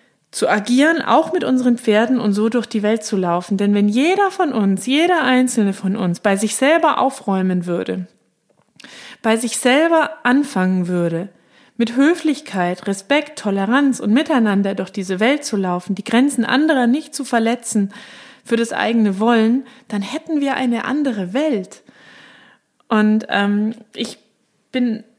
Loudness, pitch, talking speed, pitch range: -17 LUFS, 230 Hz, 150 wpm, 205-270 Hz